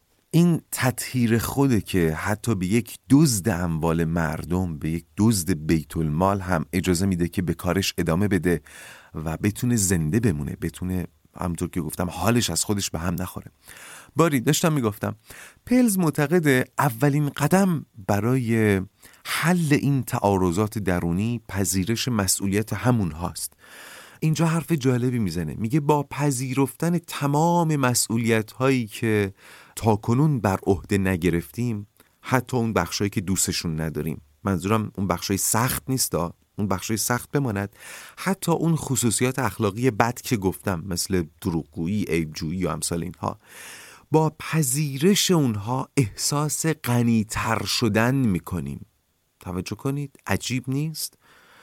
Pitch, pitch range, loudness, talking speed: 105 Hz, 90-130 Hz, -23 LUFS, 125 wpm